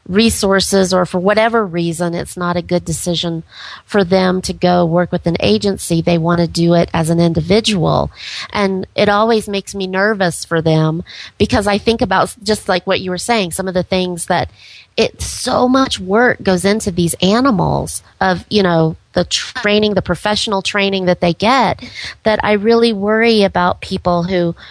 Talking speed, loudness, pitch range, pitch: 180 wpm, -15 LUFS, 175-210 Hz, 190 Hz